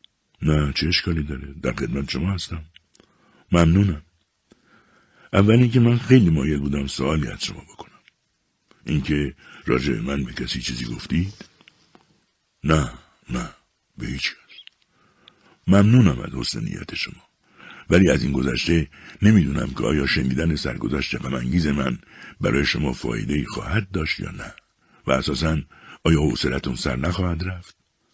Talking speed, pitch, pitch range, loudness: 130 wpm, 80 Hz, 70-90 Hz, -22 LUFS